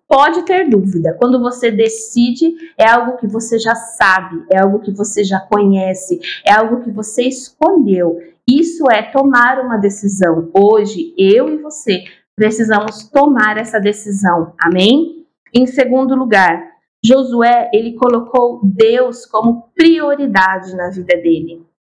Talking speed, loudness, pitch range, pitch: 135 wpm, -13 LUFS, 195-260 Hz, 225 Hz